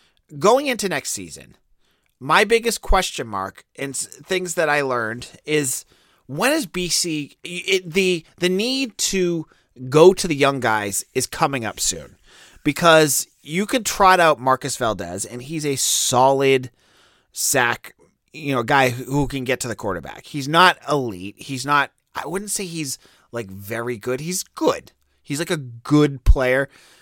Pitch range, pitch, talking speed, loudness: 125-175 Hz, 145 Hz, 160 wpm, -20 LUFS